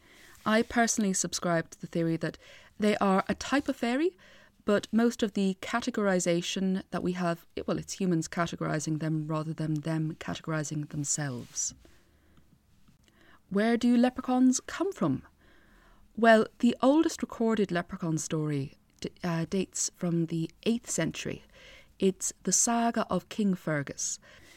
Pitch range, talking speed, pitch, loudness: 160-230 Hz, 135 wpm, 185 Hz, -29 LUFS